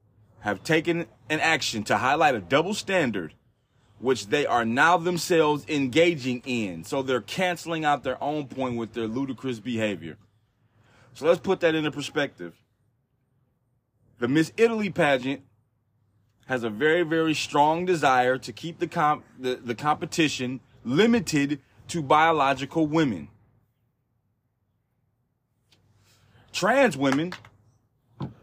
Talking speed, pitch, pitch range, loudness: 120 wpm, 130 Hz, 115-155 Hz, -25 LUFS